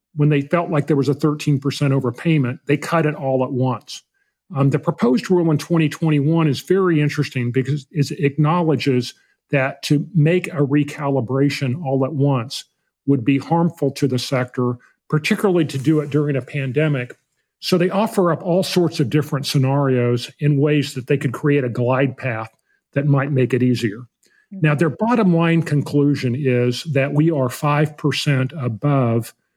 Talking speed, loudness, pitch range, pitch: 165 wpm, -19 LUFS, 130-155 Hz, 145 Hz